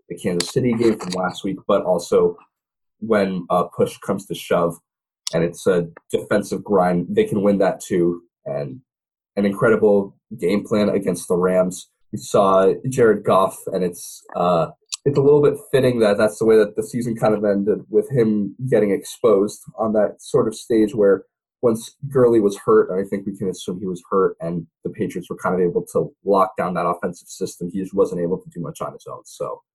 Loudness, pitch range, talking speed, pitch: -20 LUFS, 95-130 Hz, 205 wpm, 110 Hz